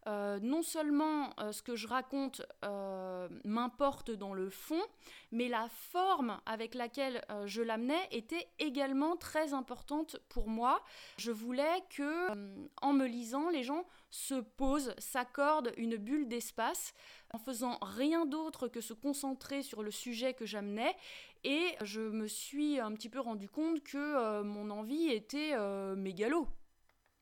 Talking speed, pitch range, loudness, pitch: 155 wpm, 220-295 Hz, -38 LUFS, 255 Hz